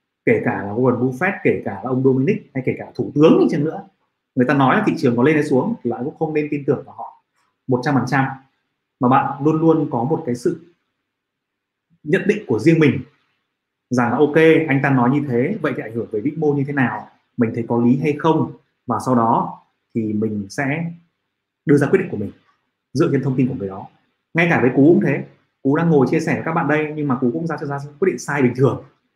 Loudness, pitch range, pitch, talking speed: -18 LUFS, 125-150 Hz, 135 Hz, 250 wpm